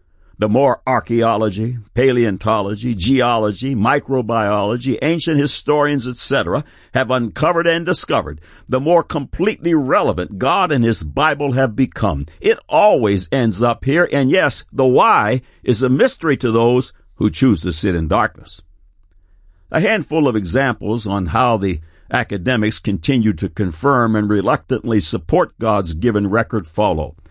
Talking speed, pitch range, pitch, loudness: 135 wpm, 100-135 Hz, 115 Hz, -16 LUFS